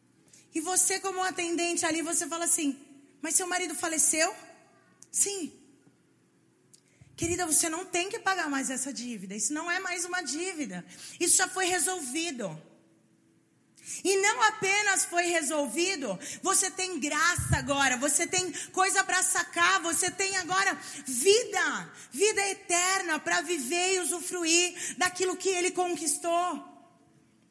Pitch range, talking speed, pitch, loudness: 320-370 Hz, 130 wpm, 350 Hz, -27 LUFS